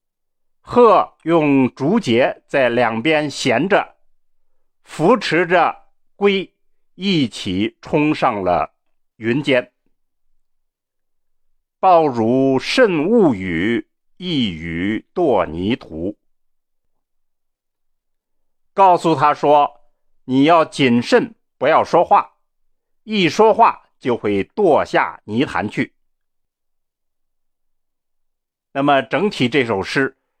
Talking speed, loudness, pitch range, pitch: 115 characters per minute, -17 LUFS, 110-165 Hz, 140 Hz